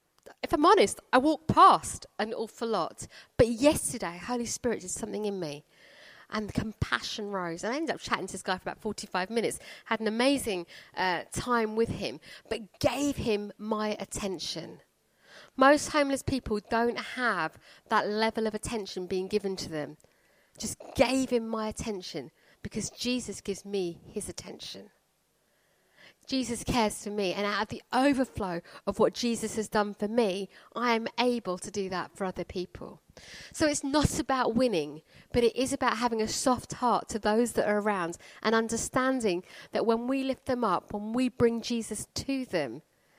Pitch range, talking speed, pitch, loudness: 195-245 Hz, 175 wpm, 220 Hz, -29 LUFS